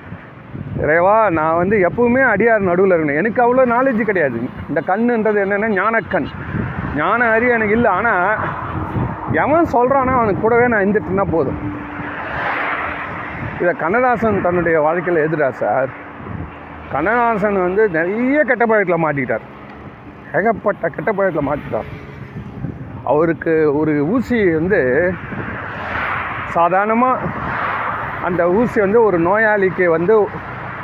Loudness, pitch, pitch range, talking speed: -16 LUFS, 195 Hz, 160-230 Hz, 100 wpm